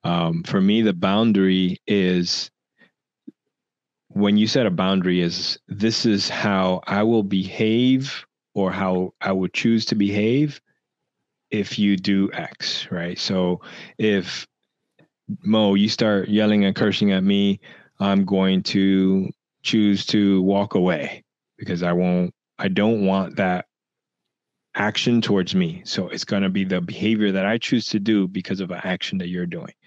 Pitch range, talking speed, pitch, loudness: 95-110 Hz, 150 wpm, 100 Hz, -21 LUFS